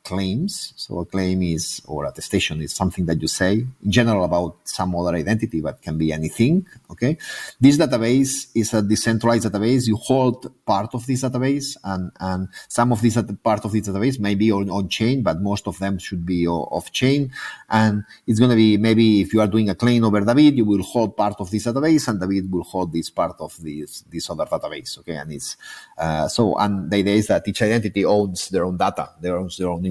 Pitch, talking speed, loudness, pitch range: 105 Hz, 225 wpm, -20 LUFS, 95-115 Hz